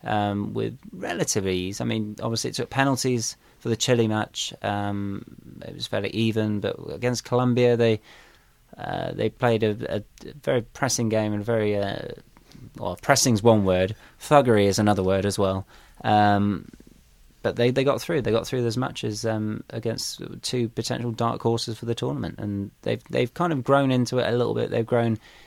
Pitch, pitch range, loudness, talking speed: 115 Hz, 105-120 Hz, -24 LUFS, 185 wpm